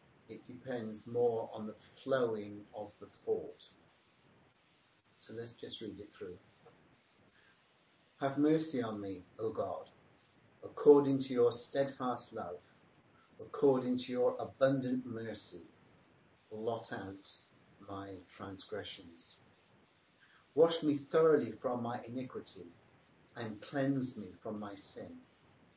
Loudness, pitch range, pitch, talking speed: -36 LUFS, 105-135 Hz, 120 Hz, 110 wpm